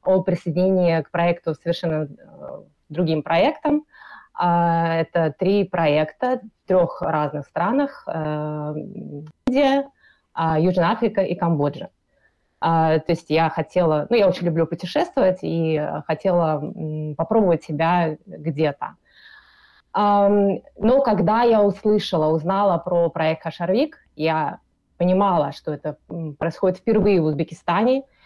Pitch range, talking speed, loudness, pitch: 160-205 Hz, 105 wpm, -21 LUFS, 170 Hz